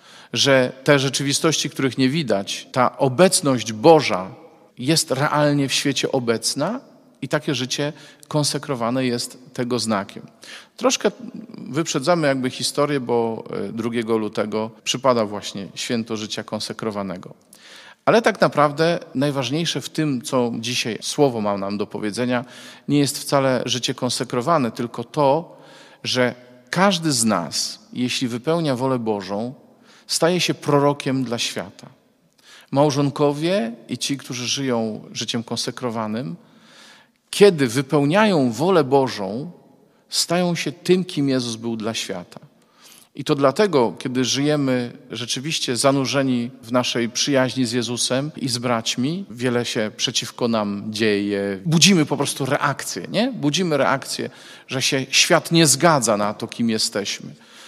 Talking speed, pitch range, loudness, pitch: 125 wpm, 120-150 Hz, -20 LUFS, 135 Hz